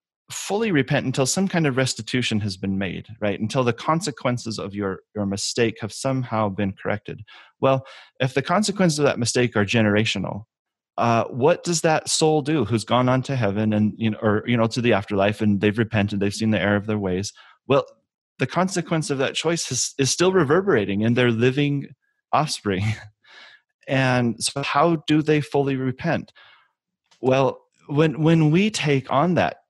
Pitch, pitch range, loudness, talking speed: 125 Hz, 105-150 Hz, -22 LUFS, 180 wpm